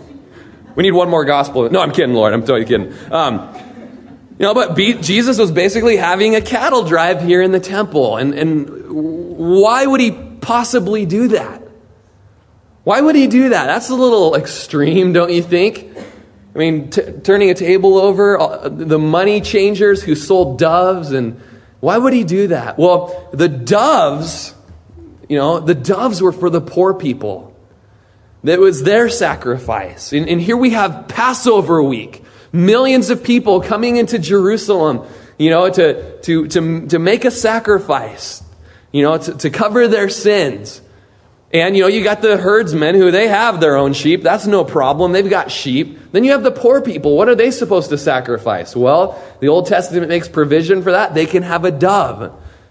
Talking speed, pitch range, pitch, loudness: 180 wpm, 145-210 Hz, 180 Hz, -13 LUFS